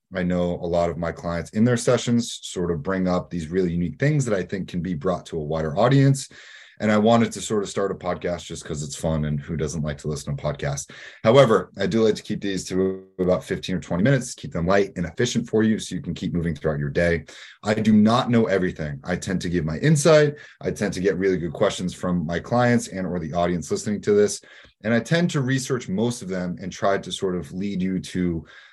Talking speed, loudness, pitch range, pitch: 255 wpm, -23 LUFS, 85-115 Hz, 90 Hz